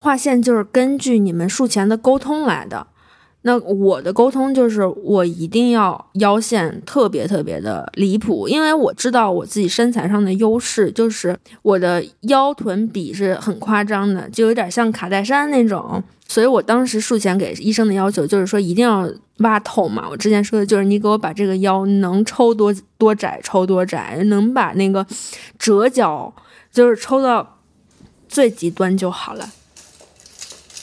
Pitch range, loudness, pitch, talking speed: 195-240 Hz, -17 LUFS, 210 Hz, 255 characters per minute